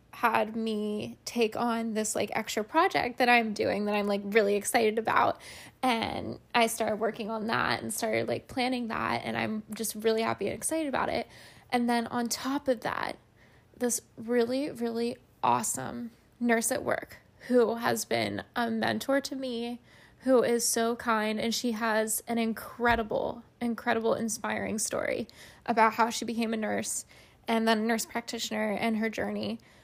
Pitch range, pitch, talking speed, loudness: 220-240 Hz, 230 Hz, 165 wpm, -29 LUFS